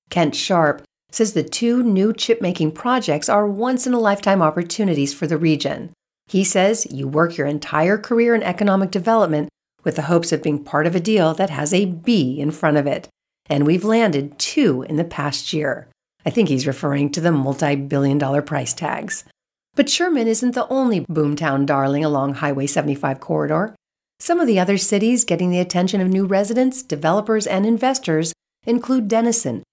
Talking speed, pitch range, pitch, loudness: 185 wpm, 150-220 Hz, 175 Hz, -19 LUFS